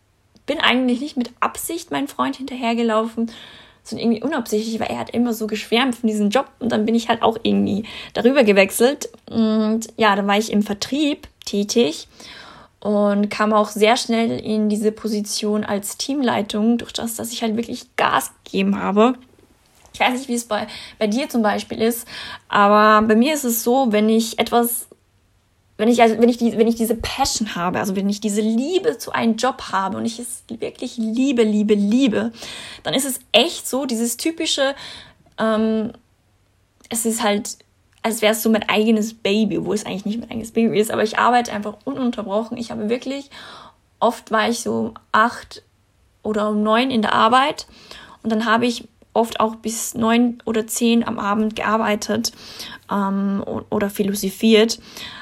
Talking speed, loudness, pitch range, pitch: 180 wpm, -19 LUFS, 210-240 Hz, 225 Hz